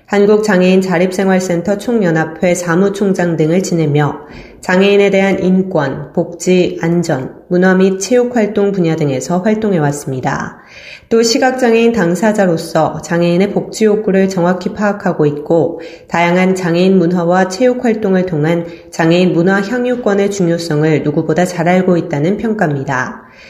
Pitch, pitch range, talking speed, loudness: 180 Hz, 165-200 Hz, 325 characters per minute, -13 LUFS